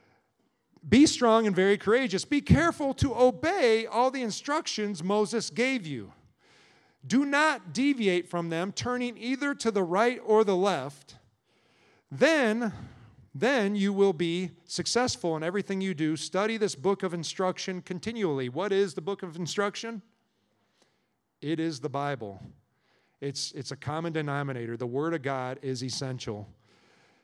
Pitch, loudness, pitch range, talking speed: 190 Hz, -28 LUFS, 150-230 Hz, 145 wpm